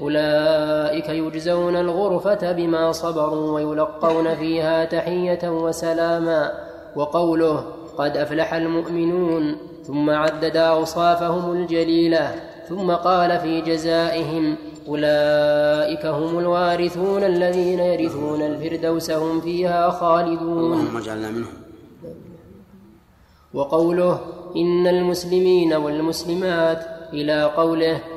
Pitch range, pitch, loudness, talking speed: 155-175 Hz, 165 Hz, -20 LUFS, 75 wpm